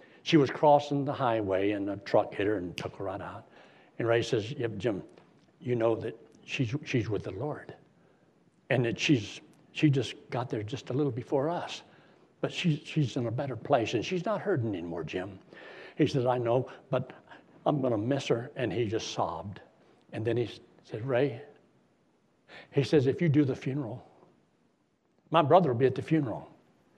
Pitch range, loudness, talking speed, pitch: 115-150 Hz, -30 LUFS, 185 wpm, 135 Hz